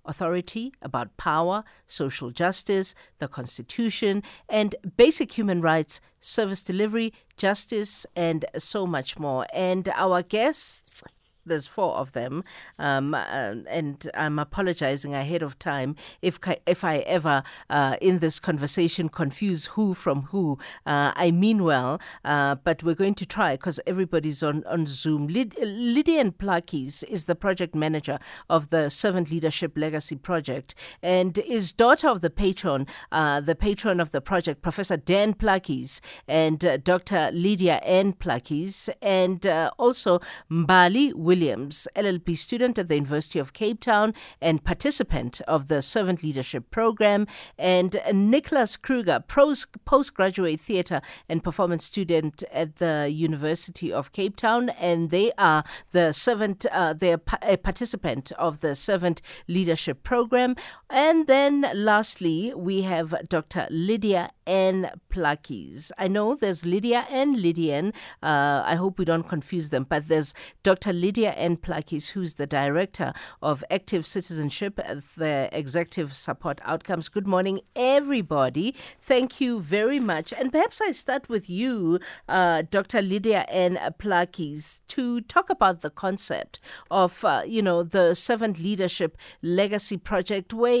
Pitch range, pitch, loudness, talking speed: 160-205 Hz, 180 Hz, -25 LUFS, 140 wpm